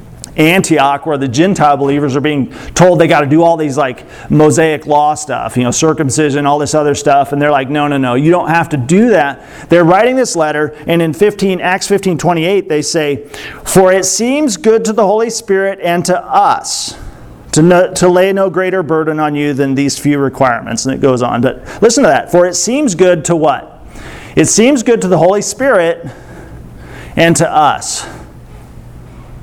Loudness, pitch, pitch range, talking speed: -11 LUFS, 165 Hz, 145-185 Hz, 200 wpm